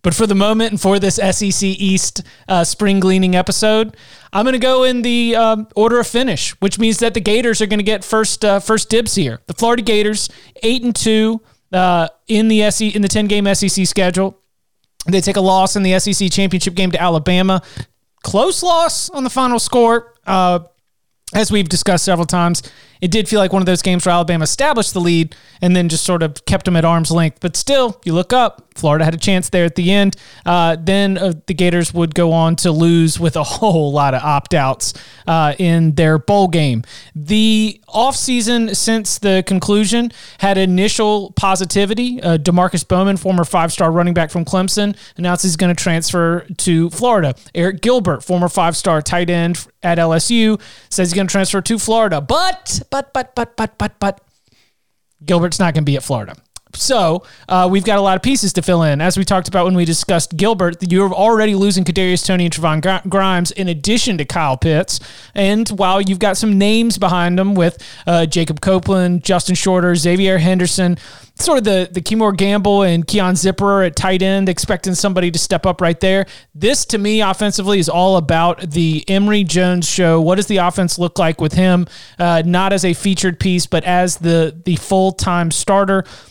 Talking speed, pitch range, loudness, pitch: 200 wpm, 175-205 Hz, -15 LUFS, 185 Hz